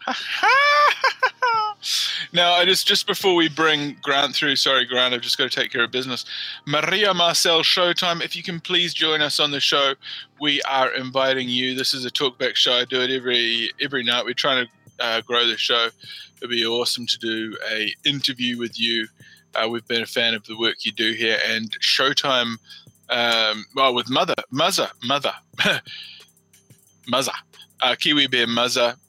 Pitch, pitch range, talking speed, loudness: 130 Hz, 120-160 Hz, 180 wpm, -20 LUFS